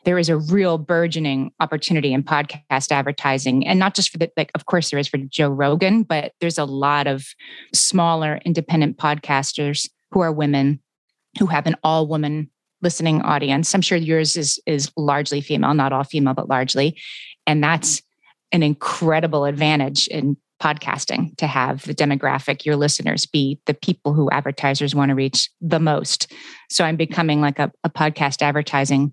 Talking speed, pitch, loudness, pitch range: 170 wpm, 150 Hz, -19 LUFS, 140-165 Hz